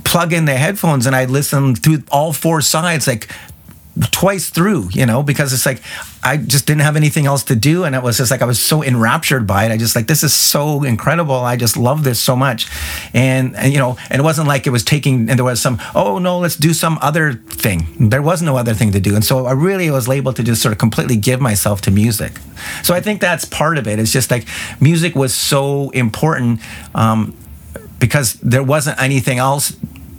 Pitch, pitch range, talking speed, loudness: 135 Hz, 115-150 Hz, 230 wpm, -14 LUFS